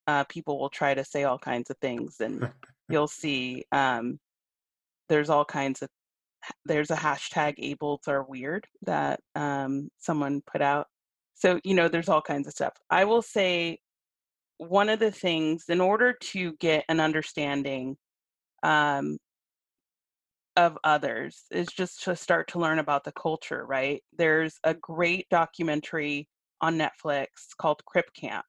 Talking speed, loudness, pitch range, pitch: 150 wpm, -27 LUFS, 140-165 Hz, 150 Hz